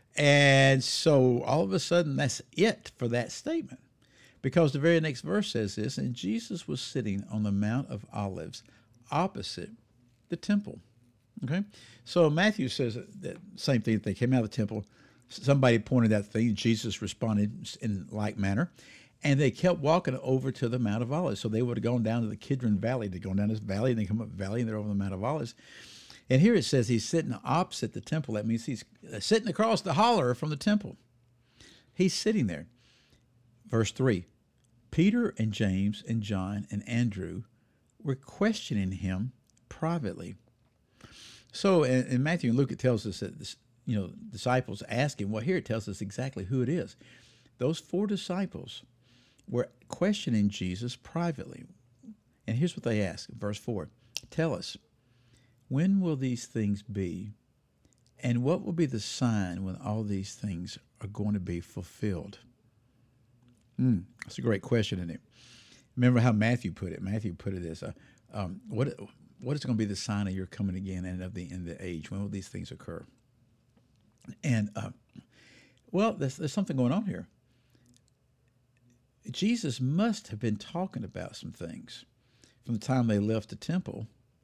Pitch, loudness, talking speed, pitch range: 120 Hz, -30 LUFS, 180 wpm, 105-140 Hz